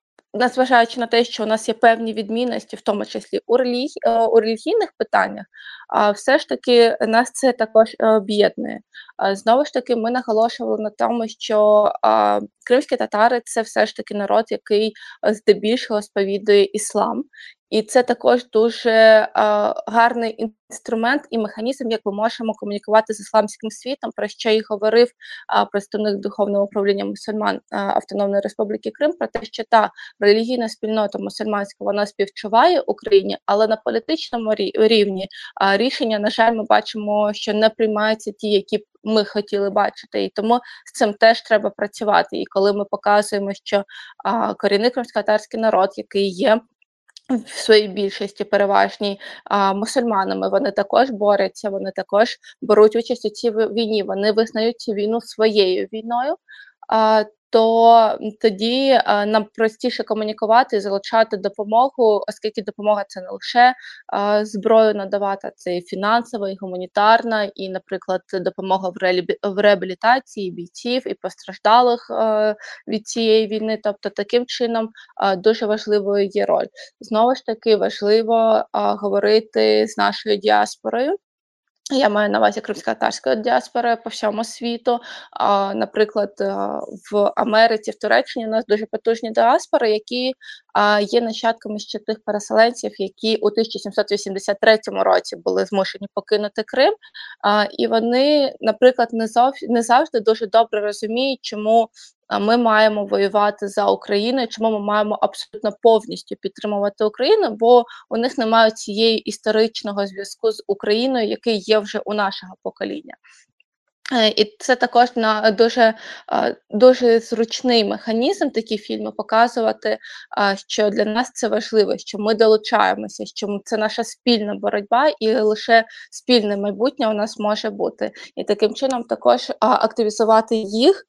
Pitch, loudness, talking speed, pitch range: 220 Hz, -19 LUFS, 135 wpm, 205-230 Hz